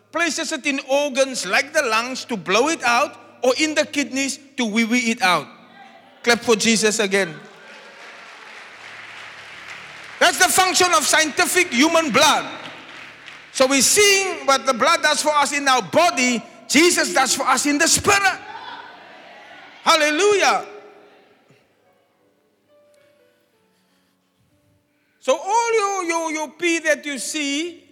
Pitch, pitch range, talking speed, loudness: 295 Hz, 260-335 Hz, 130 wpm, -18 LUFS